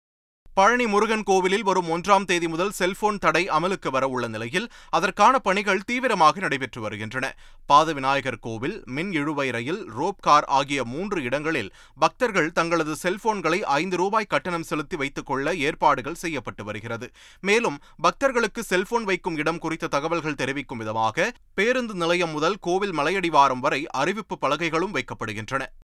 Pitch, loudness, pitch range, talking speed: 165 Hz, -23 LUFS, 135-195 Hz, 135 wpm